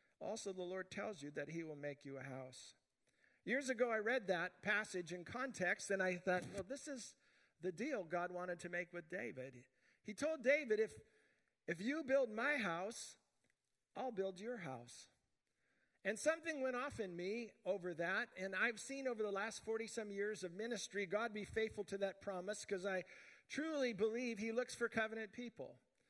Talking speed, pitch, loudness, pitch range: 185 wpm, 210 Hz, -43 LUFS, 180-245 Hz